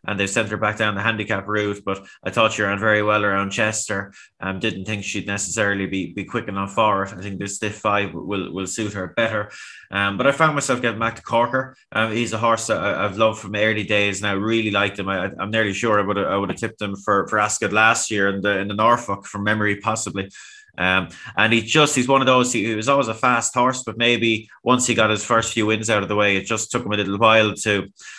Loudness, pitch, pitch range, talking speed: -20 LUFS, 105 Hz, 100-115 Hz, 260 wpm